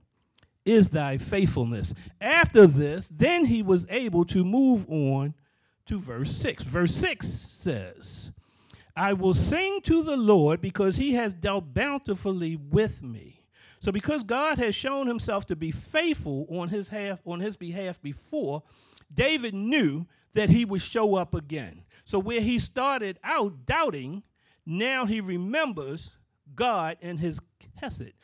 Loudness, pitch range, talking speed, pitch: -26 LUFS, 155-230 Hz, 145 wpm, 190 Hz